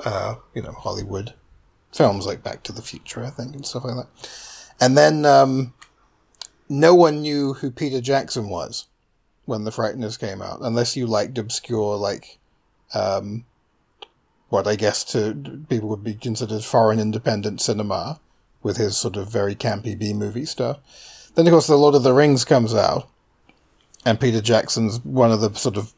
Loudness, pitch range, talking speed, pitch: -20 LUFS, 110-135 Hz, 175 wpm, 120 Hz